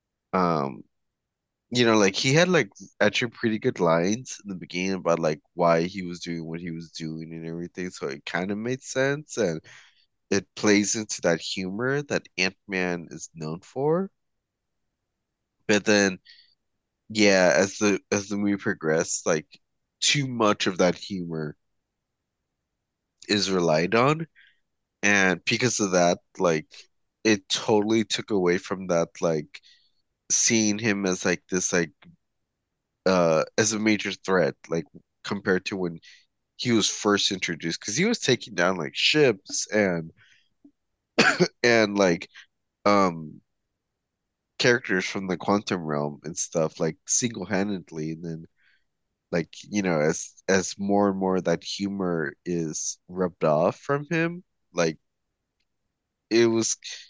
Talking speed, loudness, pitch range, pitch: 140 wpm, -25 LUFS, 85-110 Hz, 95 Hz